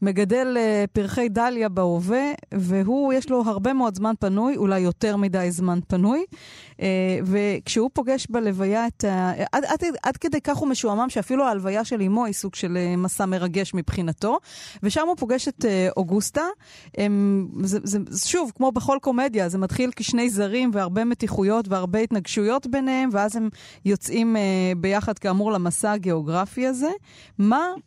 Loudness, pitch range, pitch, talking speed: -23 LUFS, 195-250 Hz, 215 Hz, 145 wpm